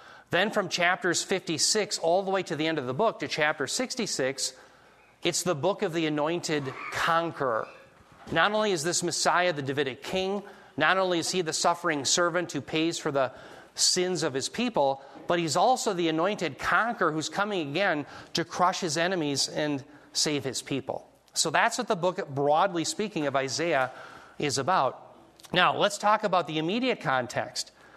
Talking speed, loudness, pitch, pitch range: 175 wpm, -27 LUFS, 170 Hz, 150-190 Hz